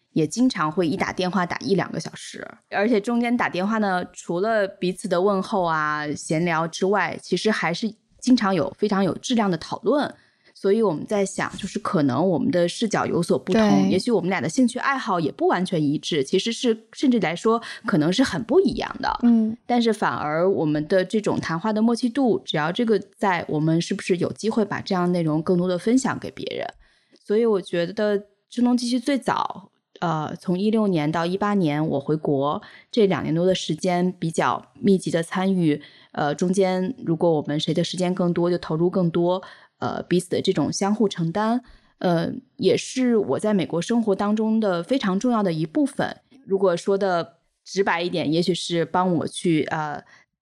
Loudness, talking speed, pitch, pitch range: -23 LUFS, 285 characters per minute, 190 Hz, 170-220 Hz